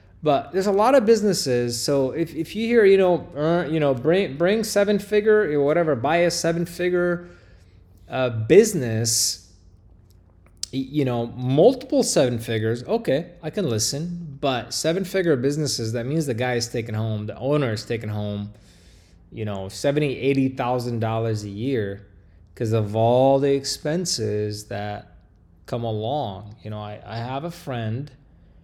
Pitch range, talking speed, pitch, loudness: 105-160 Hz, 155 wpm, 125 Hz, -22 LUFS